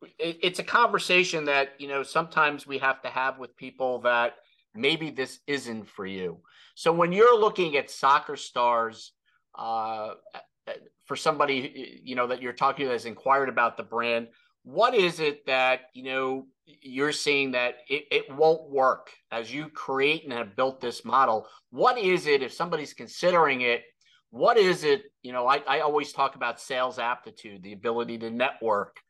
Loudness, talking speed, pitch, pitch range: -26 LUFS, 175 wpm, 135 Hz, 120-160 Hz